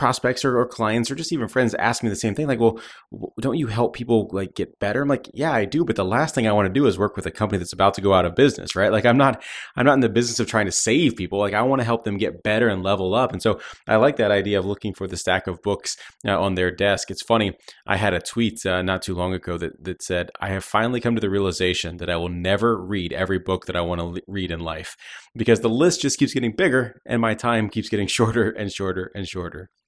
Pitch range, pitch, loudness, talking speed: 95-120 Hz, 105 Hz, -22 LUFS, 285 wpm